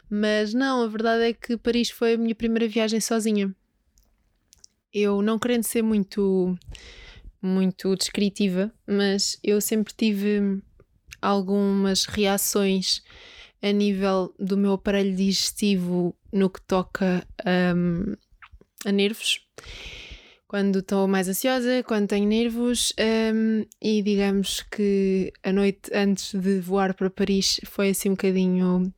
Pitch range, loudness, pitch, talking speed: 195-220 Hz, -24 LUFS, 200 Hz, 125 wpm